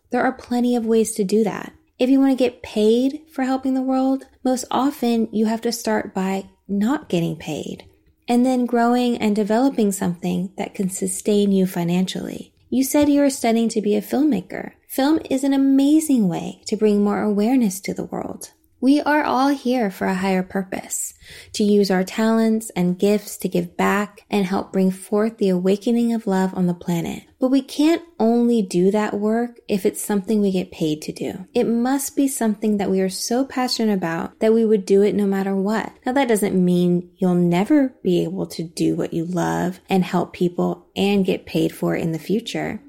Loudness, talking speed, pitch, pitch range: -20 LUFS, 205 wpm, 210 Hz, 190-245 Hz